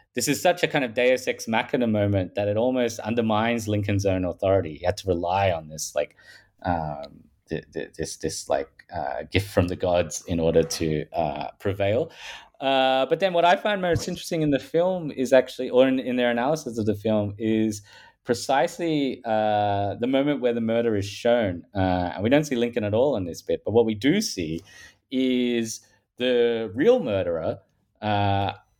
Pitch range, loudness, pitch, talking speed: 100-130 Hz, -24 LUFS, 115 Hz, 190 wpm